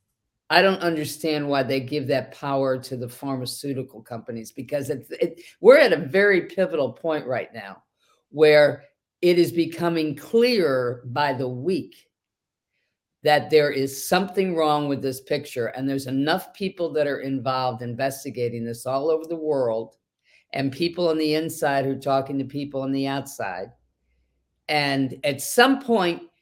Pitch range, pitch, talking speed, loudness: 130-160 Hz, 140 Hz, 155 wpm, -23 LUFS